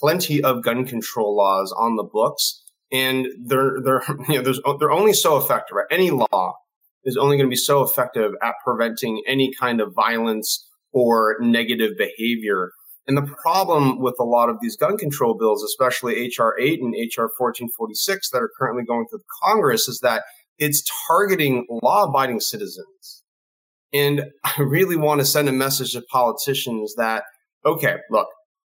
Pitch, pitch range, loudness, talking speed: 130 Hz, 120-150 Hz, -20 LUFS, 165 wpm